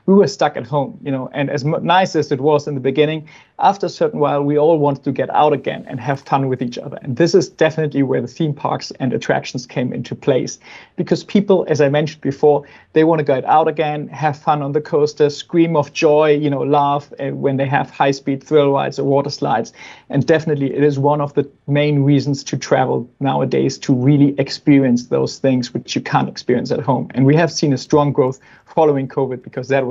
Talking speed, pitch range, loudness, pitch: 225 wpm, 135-155 Hz, -17 LUFS, 145 Hz